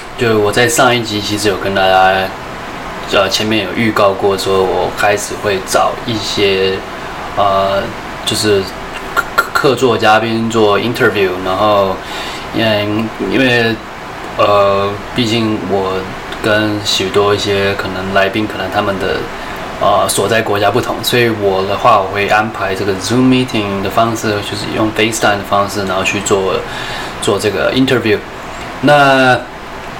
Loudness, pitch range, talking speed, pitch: -13 LUFS, 100-115 Hz, 265 characters per minute, 105 Hz